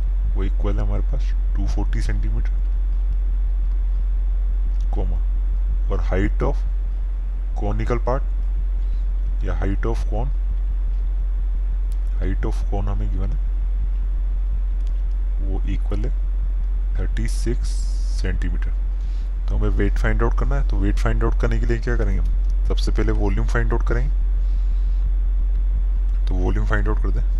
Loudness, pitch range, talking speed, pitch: -24 LUFS, 60-100 Hz, 120 wpm, 70 Hz